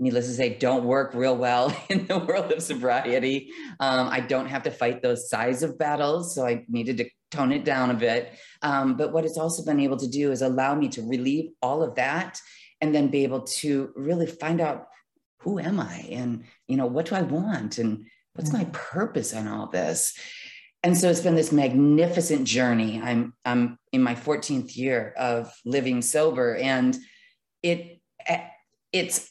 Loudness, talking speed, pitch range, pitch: -25 LUFS, 190 wpm, 125-155 Hz, 135 Hz